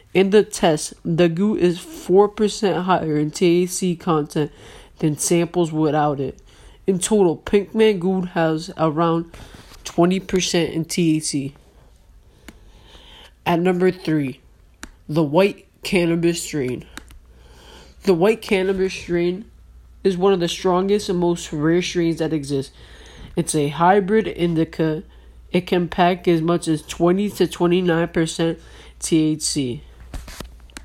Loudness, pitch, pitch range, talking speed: -20 LUFS, 175 Hz, 160-185 Hz, 120 wpm